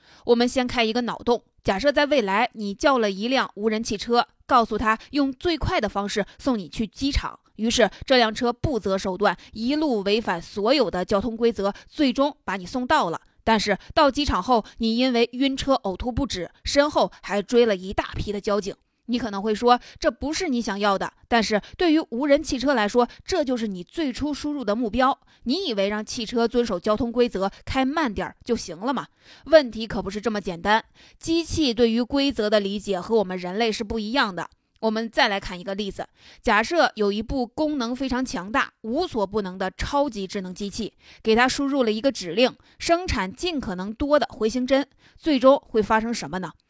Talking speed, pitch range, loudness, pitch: 290 characters per minute, 205-270 Hz, -23 LUFS, 235 Hz